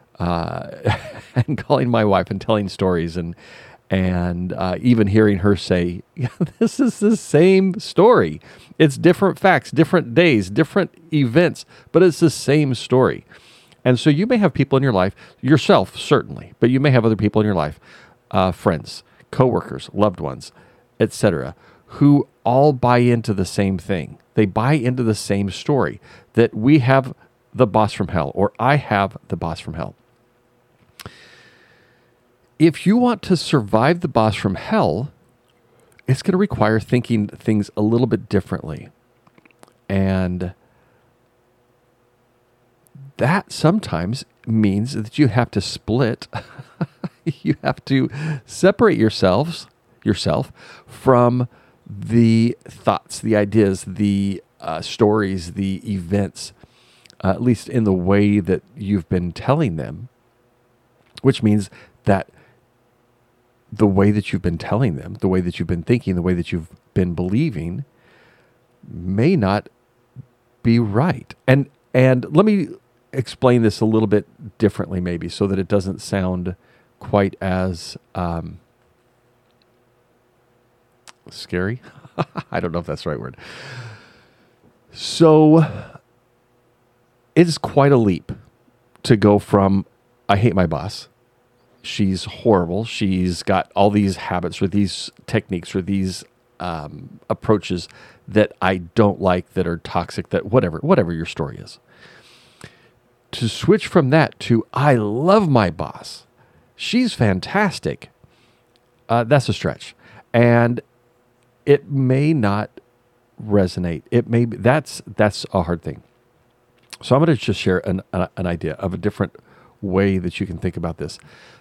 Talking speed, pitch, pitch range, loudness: 140 wpm, 120 Hz, 100-125 Hz, -19 LUFS